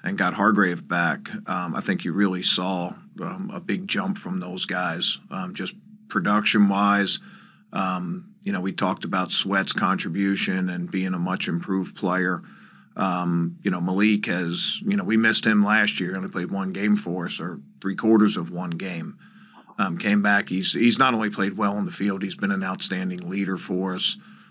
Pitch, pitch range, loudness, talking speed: 100 Hz, 95-110 Hz, -23 LUFS, 190 wpm